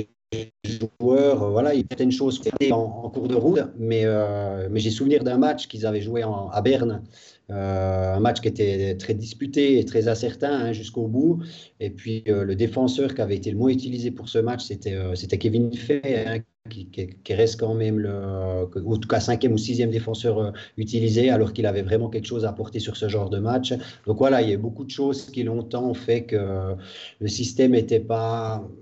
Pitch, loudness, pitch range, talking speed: 115 Hz, -24 LUFS, 105-125 Hz, 210 wpm